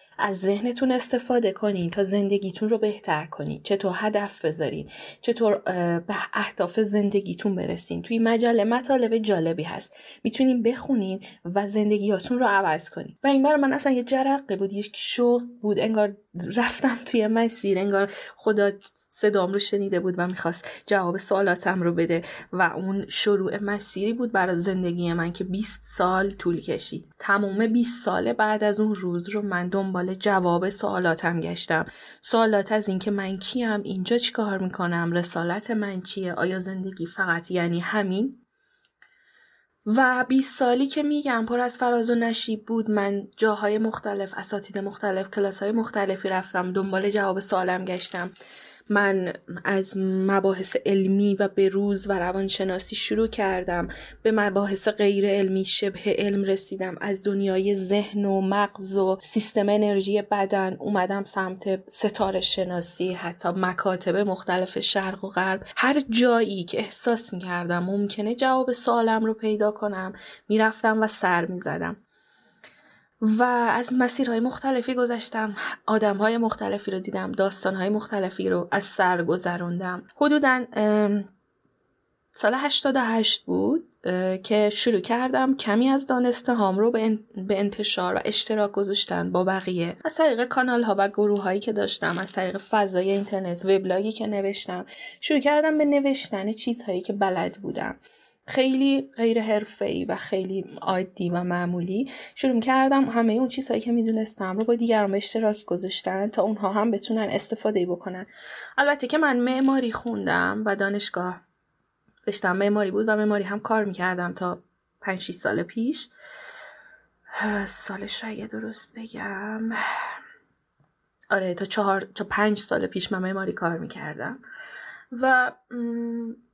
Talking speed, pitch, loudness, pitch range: 140 wpm, 205 Hz, -24 LUFS, 190-230 Hz